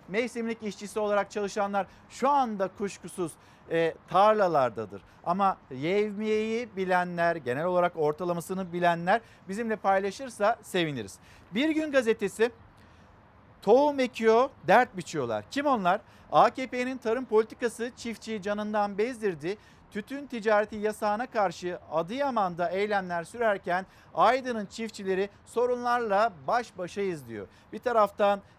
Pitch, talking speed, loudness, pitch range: 200 Hz, 105 wpm, -28 LUFS, 175-225 Hz